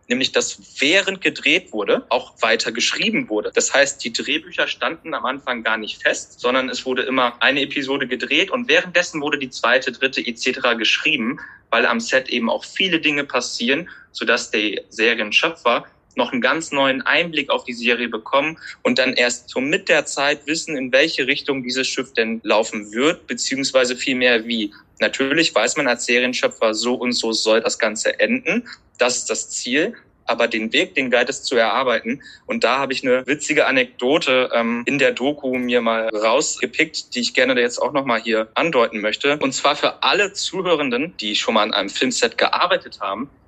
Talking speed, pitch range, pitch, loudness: 185 wpm, 120-145 Hz, 130 Hz, -19 LUFS